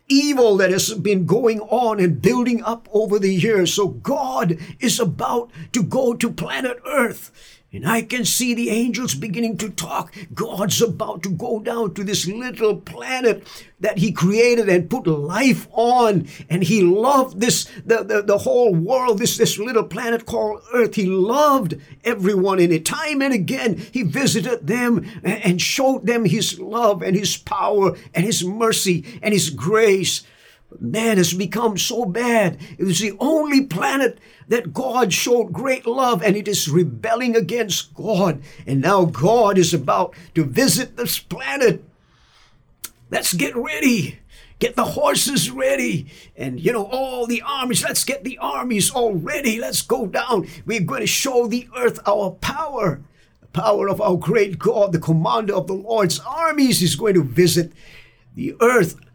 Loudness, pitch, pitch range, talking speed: -19 LUFS, 215 Hz, 180-235 Hz, 165 wpm